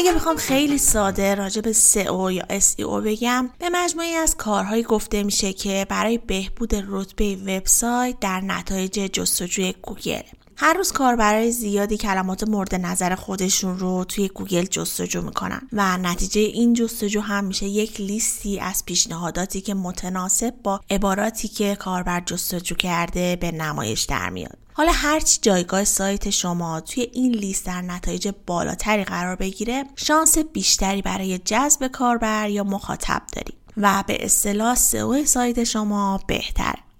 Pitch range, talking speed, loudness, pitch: 190-230 Hz, 145 wpm, -21 LUFS, 200 Hz